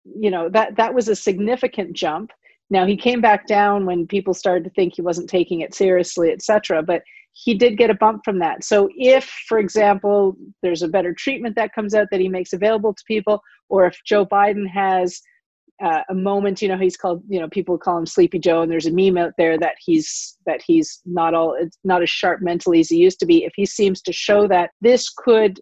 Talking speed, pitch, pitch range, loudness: 230 wpm, 200 Hz, 180-225 Hz, -18 LUFS